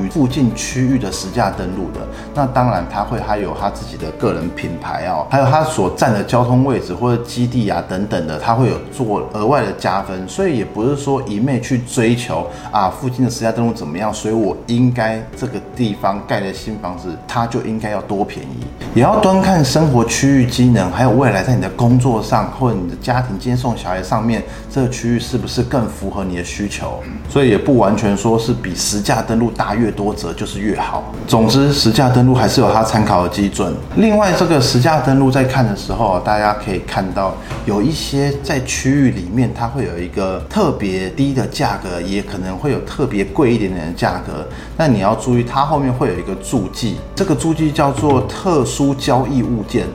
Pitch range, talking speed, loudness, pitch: 100-130 Hz, 310 characters per minute, -16 LUFS, 115 Hz